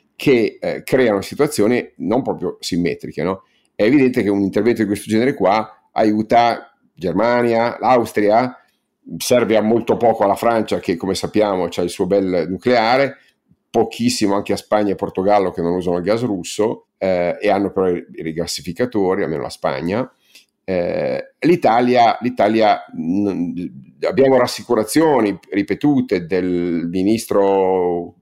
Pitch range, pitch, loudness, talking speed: 95-120 Hz, 105 Hz, -18 LUFS, 135 wpm